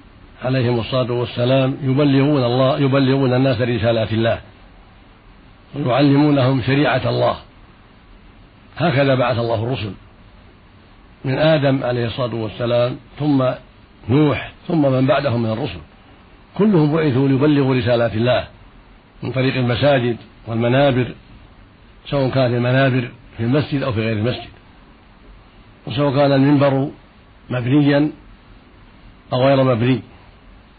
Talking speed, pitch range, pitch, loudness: 105 wpm, 110-135 Hz, 125 Hz, -17 LUFS